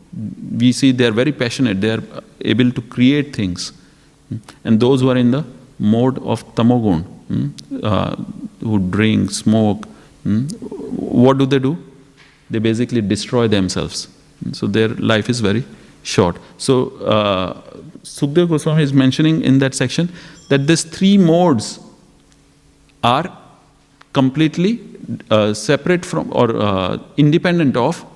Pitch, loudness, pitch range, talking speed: 130 Hz, -16 LUFS, 110-150 Hz, 135 wpm